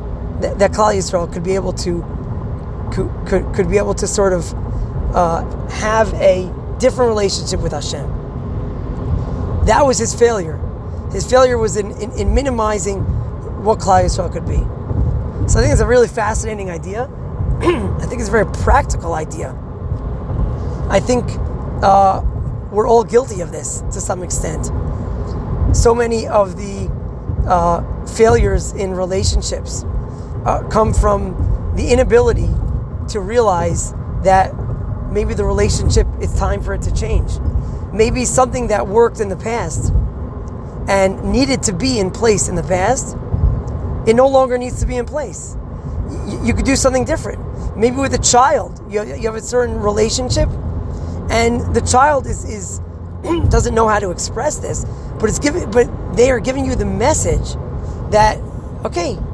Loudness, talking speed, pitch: -17 LUFS, 155 wpm, 205 Hz